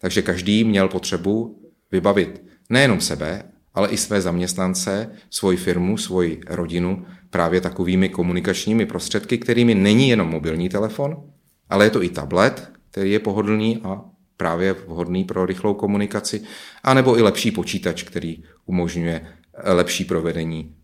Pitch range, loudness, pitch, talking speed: 90-105 Hz, -20 LUFS, 95 Hz, 130 wpm